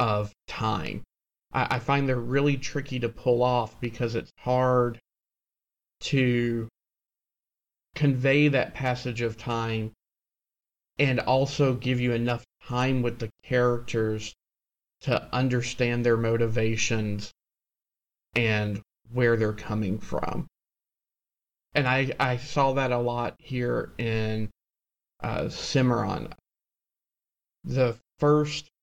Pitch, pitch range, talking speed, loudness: 120 Hz, 115-130 Hz, 105 wpm, -27 LUFS